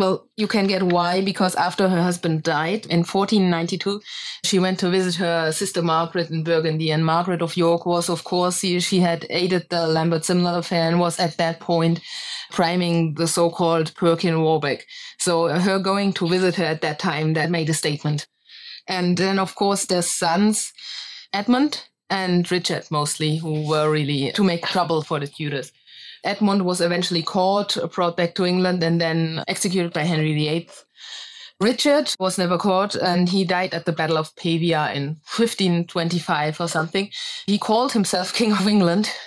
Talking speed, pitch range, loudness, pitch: 175 wpm, 165-190 Hz, -21 LUFS, 175 Hz